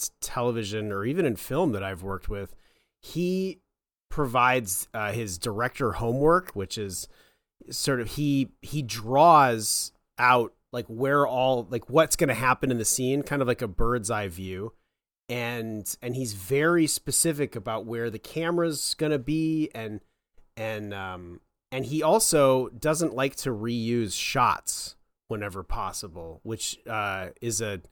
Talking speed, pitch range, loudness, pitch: 150 wpm, 110-140 Hz, -26 LUFS, 120 Hz